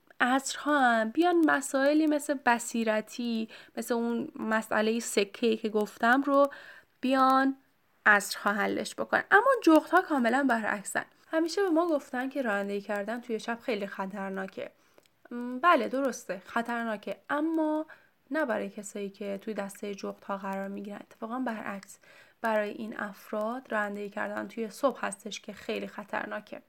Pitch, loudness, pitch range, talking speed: 230 Hz, -29 LUFS, 210-275 Hz, 140 wpm